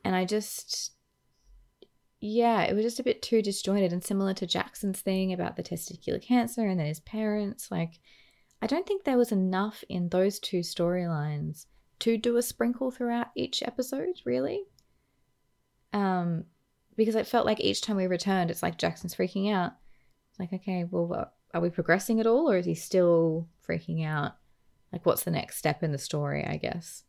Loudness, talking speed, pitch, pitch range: -29 LUFS, 185 wpm, 190 Hz, 170-225 Hz